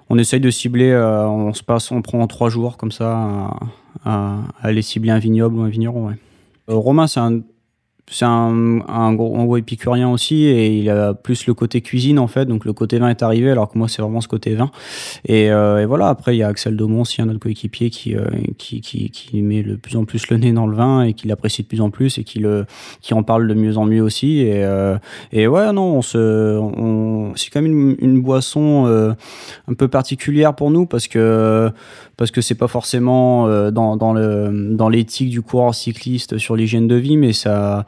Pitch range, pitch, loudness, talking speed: 110-125 Hz, 115 Hz, -16 LUFS, 235 wpm